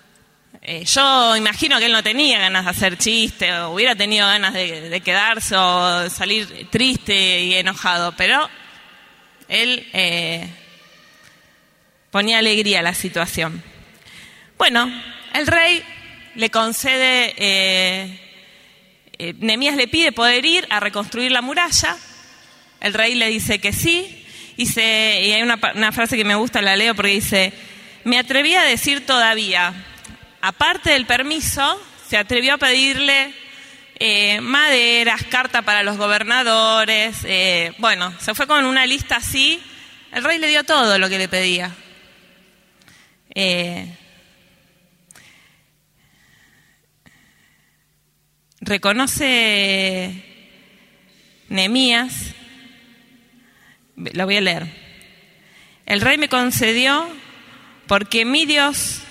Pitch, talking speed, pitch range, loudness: 215 Hz, 120 wpm, 190-250 Hz, -16 LUFS